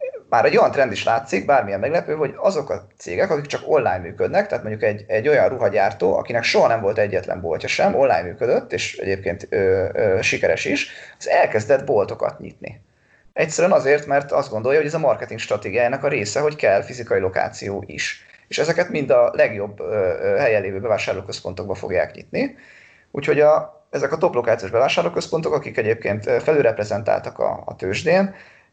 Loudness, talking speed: -20 LUFS, 170 wpm